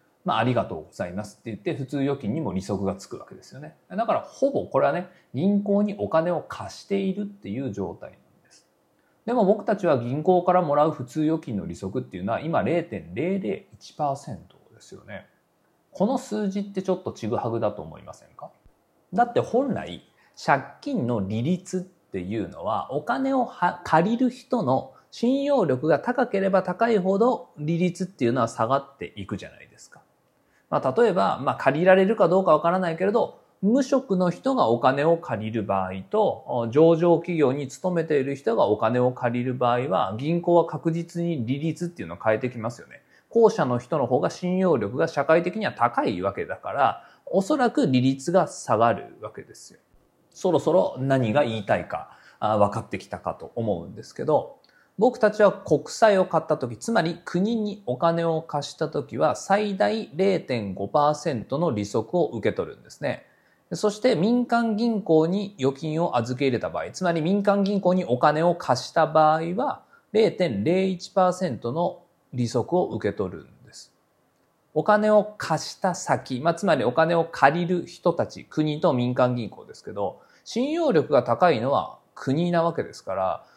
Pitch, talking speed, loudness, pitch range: 170 Hz, 330 characters per minute, -24 LUFS, 130-195 Hz